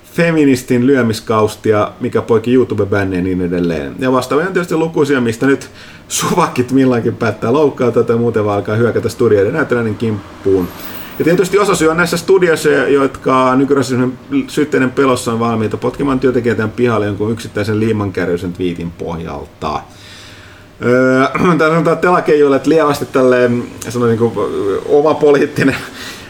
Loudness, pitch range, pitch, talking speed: -14 LUFS, 110-140 Hz, 125 Hz, 140 wpm